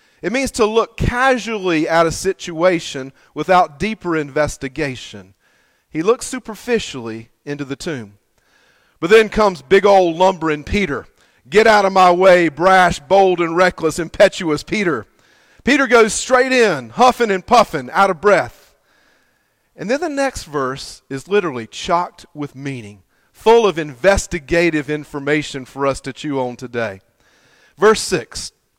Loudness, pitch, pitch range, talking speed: -16 LUFS, 170 Hz, 140-205 Hz, 140 wpm